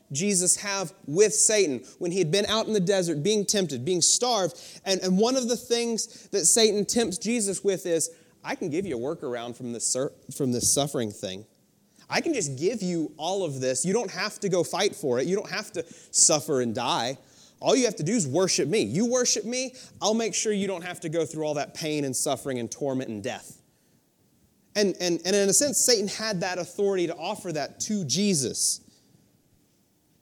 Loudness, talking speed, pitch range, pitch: -25 LUFS, 215 wpm, 165-210 Hz, 190 Hz